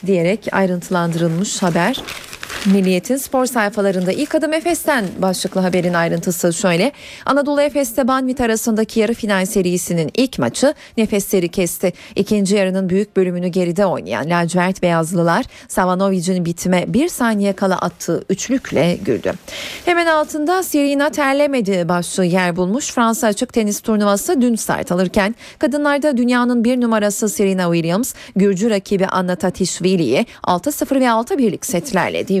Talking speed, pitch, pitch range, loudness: 130 wpm, 200 Hz, 185-250 Hz, -17 LUFS